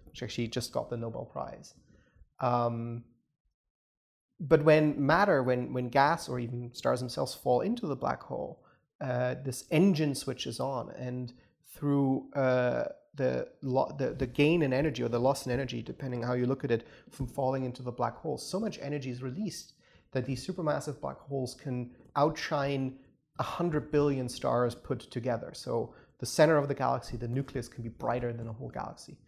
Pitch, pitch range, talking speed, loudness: 130 Hz, 125-145 Hz, 180 wpm, -31 LUFS